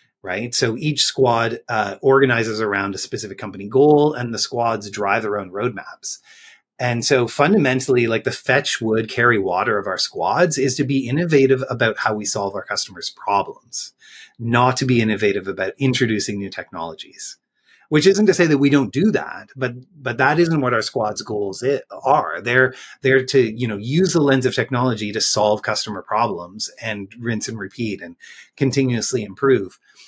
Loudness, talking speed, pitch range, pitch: -19 LUFS, 180 wpm, 110-135 Hz, 120 Hz